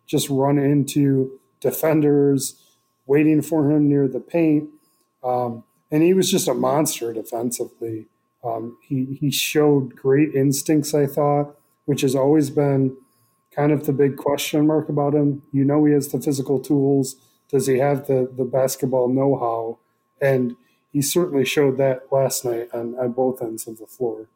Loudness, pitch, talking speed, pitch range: -20 LUFS, 140 Hz, 165 wpm, 130-145 Hz